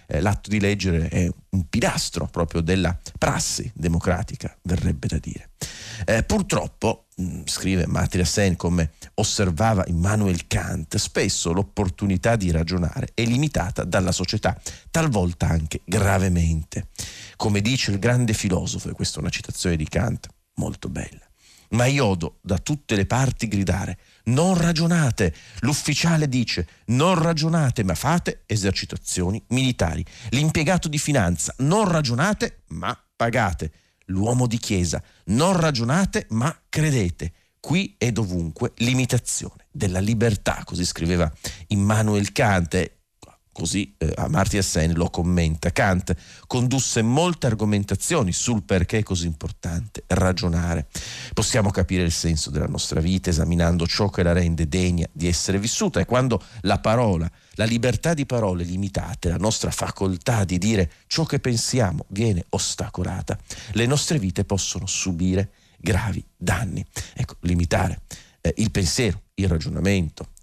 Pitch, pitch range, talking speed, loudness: 100 Hz, 90-115 Hz, 130 wpm, -23 LUFS